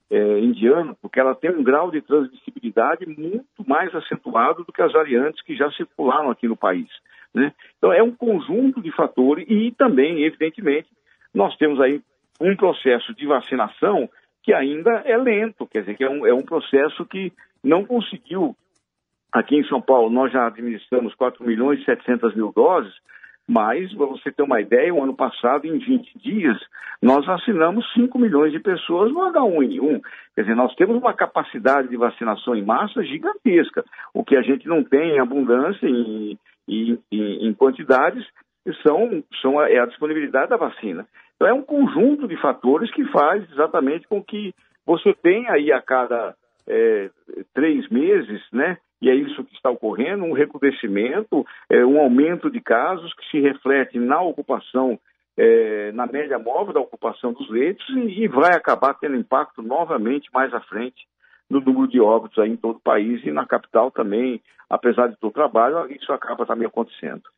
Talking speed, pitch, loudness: 175 wpm, 150 Hz, -20 LUFS